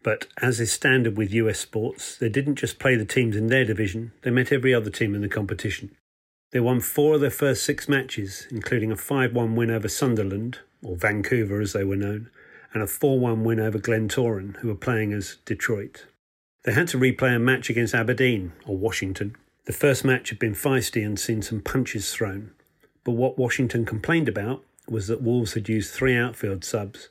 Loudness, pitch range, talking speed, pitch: -24 LUFS, 105-130 Hz, 200 wpm, 115 Hz